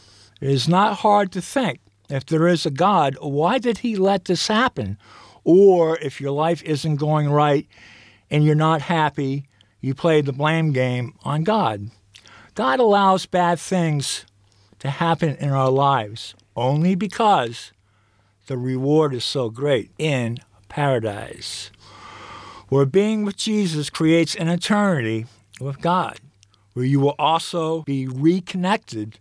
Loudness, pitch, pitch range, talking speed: -20 LUFS, 145 Hz, 120-170 Hz, 140 wpm